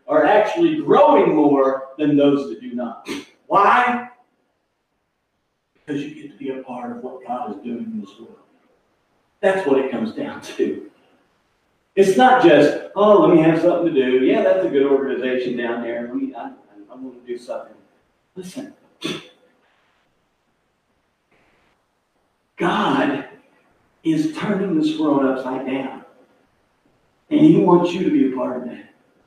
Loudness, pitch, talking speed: -18 LUFS, 155 Hz, 155 wpm